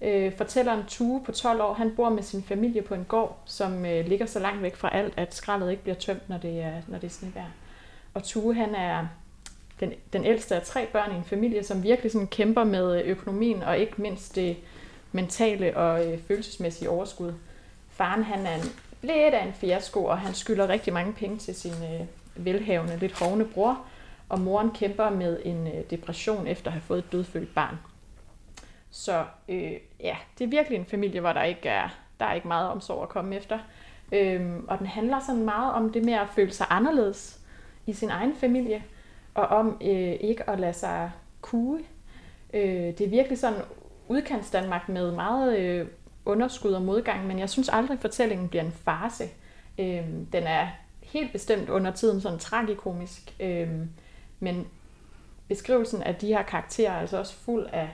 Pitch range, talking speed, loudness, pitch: 180-220 Hz, 180 wpm, -28 LUFS, 200 Hz